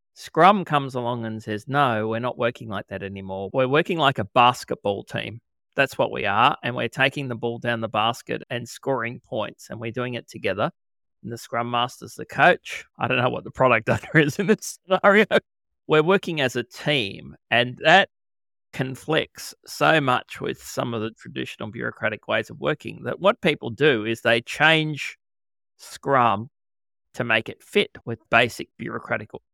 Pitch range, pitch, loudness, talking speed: 110-145 Hz, 120 Hz, -23 LUFS, 180 wpm